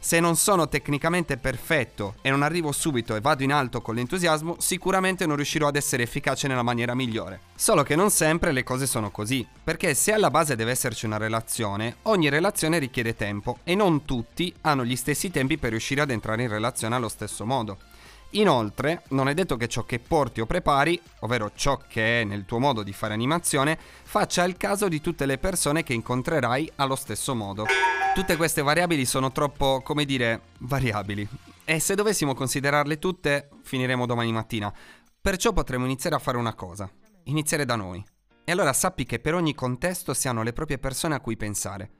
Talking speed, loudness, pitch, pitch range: 190 wpm, -25 LUFS, 135 Hz, 115-160 Hz